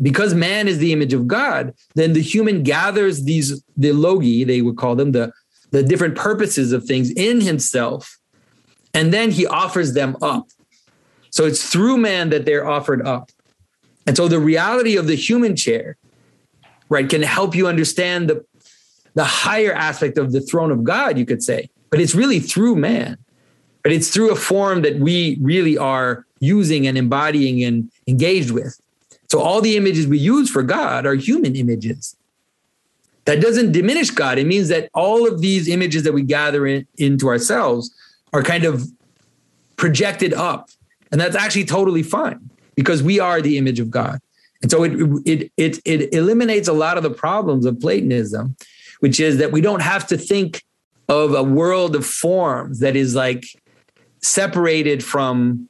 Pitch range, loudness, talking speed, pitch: 135-185 Hz, -17 LUFS, 175 wpm, 155 Hz